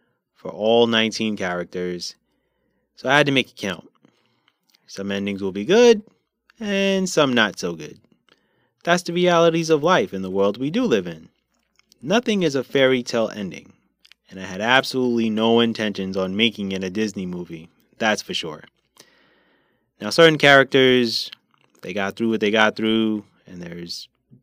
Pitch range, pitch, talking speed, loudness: 100-150 Hz, 115 Hz, 160 wpm, -20 LUFS